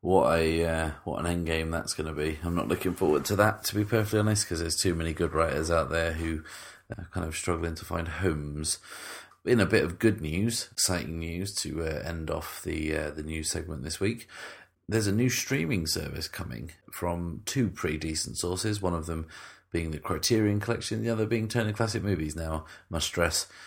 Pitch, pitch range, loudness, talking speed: 85 Hz, 80-105 Hz, -29 LUFS, 210 wpm